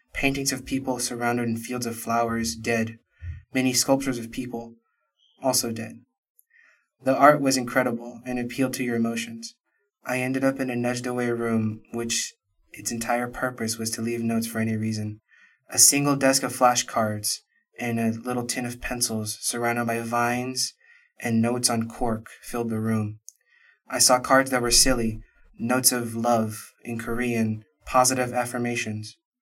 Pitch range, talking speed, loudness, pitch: 115-130 Hz, 155 wpm, -24 LUFS, 120 Hz